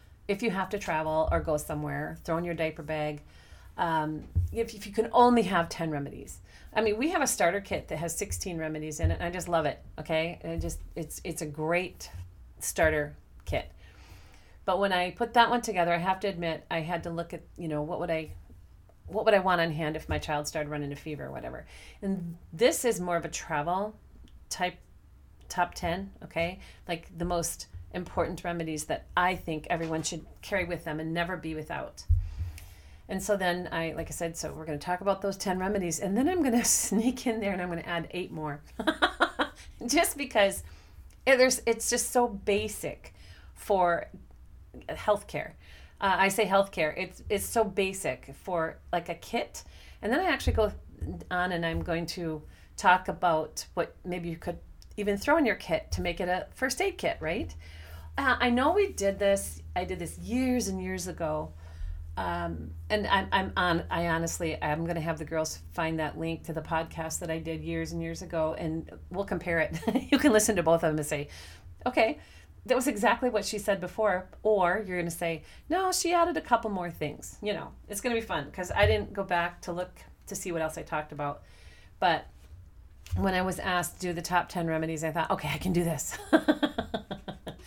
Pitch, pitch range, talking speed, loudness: 170 Hz, 150-200 Hz, 210 wpm, -30 LUFS